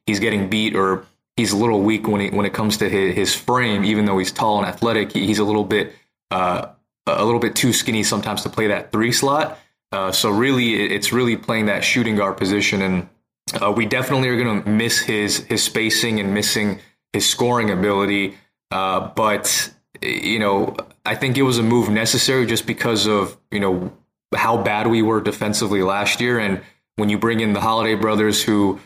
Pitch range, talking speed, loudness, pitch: 100-115 Hz, 205 wpm, -19 LUFS, 105 Hz